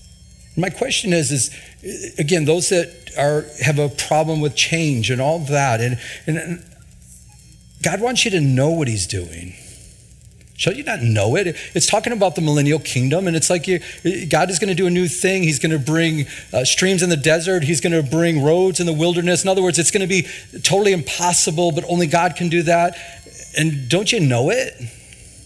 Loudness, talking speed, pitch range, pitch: -18 LUFS, 205 wpm, 145-180 Hz, 165 Hz